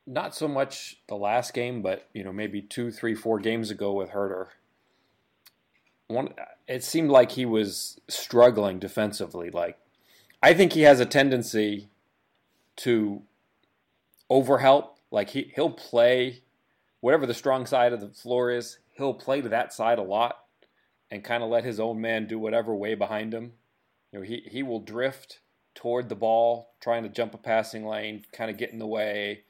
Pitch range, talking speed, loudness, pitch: 105-125 Hz, 175 wpm, -26 LUFS, 115 Hz